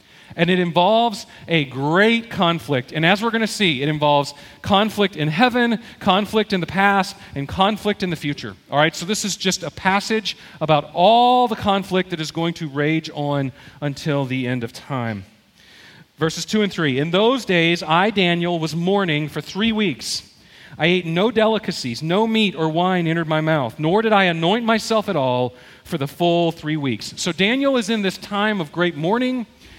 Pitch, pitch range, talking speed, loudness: 175 Hz, 150-205 Hz, 190 wpm, -19 LUFS